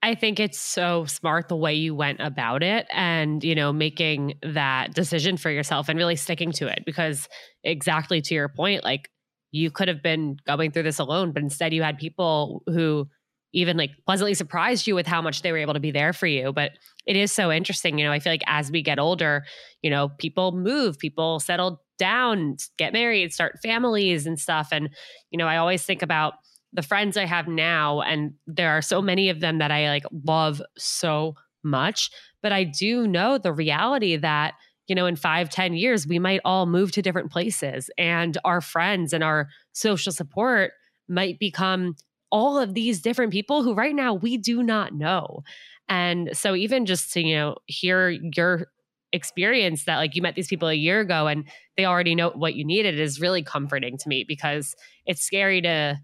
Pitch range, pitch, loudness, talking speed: 155-190 Hz, 170 Hz, -23 LUFS, 200 wpm